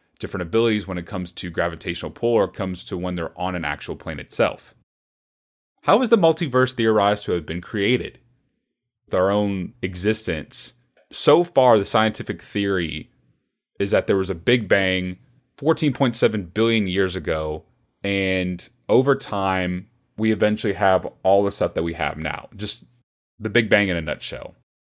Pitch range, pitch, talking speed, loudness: 90-115 Hz, 100 Hz, 160 wpm, -22 LUFS